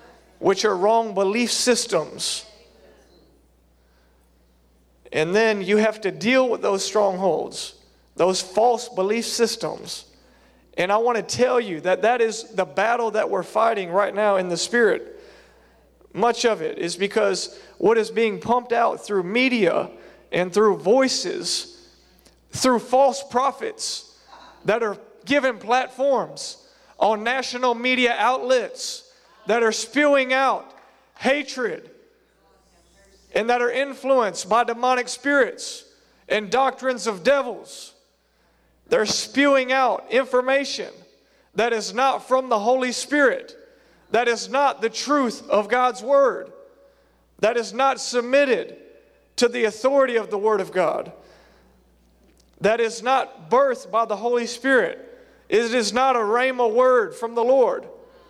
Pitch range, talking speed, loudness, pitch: 215-275 Hz, 130 wpm, -21 LUFS, 245 Hz